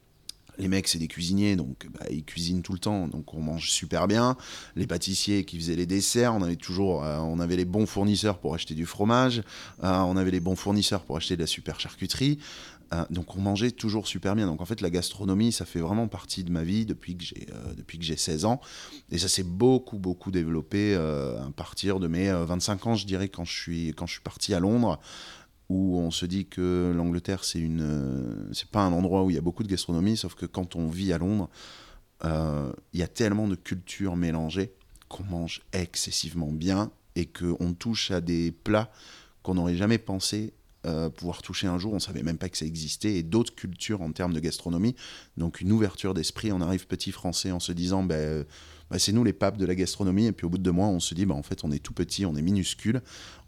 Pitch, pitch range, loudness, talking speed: 90 Hz, 85-100 Hz, -28 LUFS, 235 wpm